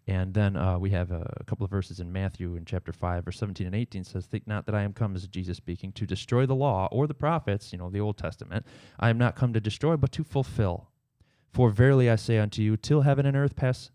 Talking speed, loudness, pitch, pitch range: 260 wpm, -28 LUFS, 105 Hz, 95-125 Hz